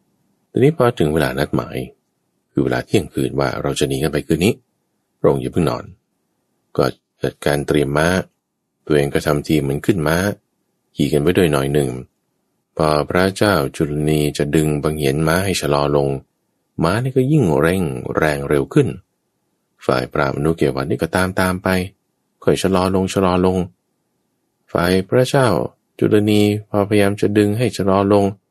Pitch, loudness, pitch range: 80 Hz, -18 LUFS, 75-100 Hz